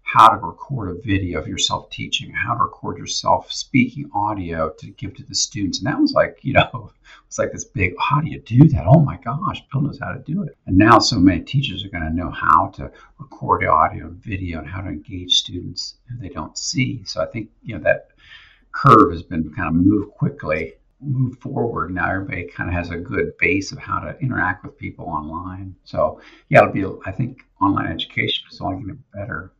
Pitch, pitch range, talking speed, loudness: 95 Hz, 85-135 Hz, 225 wpm, -19 LUFS